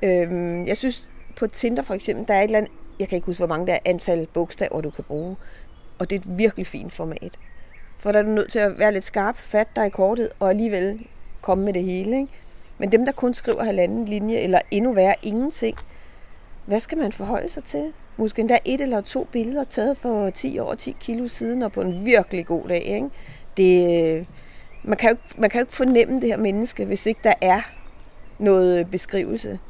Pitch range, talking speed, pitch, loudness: 180-230 Hz, 210 wpm, 205 Hz, -22 LUFS